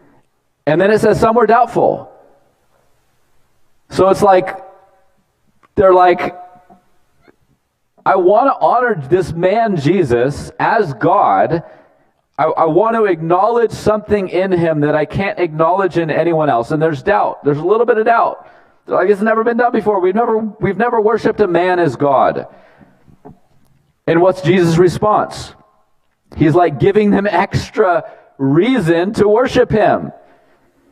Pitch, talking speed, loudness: 175 Hz, 145 wpm, -13 LUFS